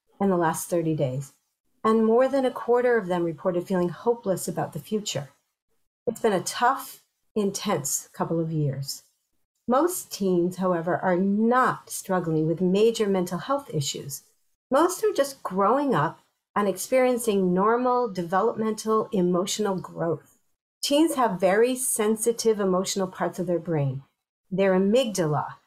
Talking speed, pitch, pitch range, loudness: 140 wpm, 195 Hz, 175-235 Hz, -25 LUFS